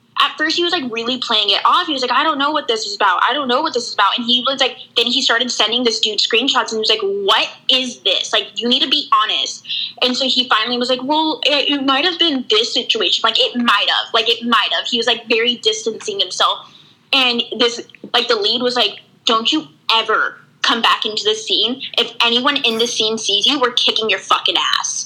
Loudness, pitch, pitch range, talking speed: -15 LUFS, 245 Hz, 230-290 Hz, 250 wpm